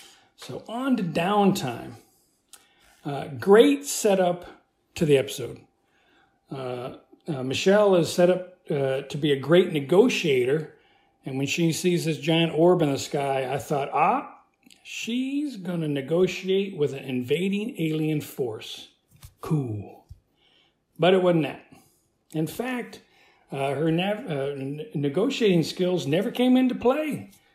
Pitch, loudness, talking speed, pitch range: 175 Hz, -24 LUFS, 135 wpm, 145-215 Hz